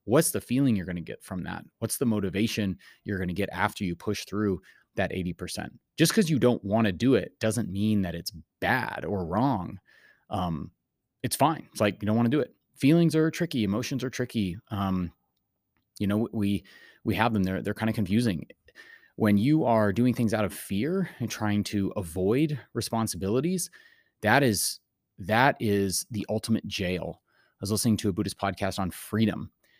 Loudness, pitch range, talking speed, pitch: -27 LUFS, 100-120 Hz, 195 wpm, 105 Hz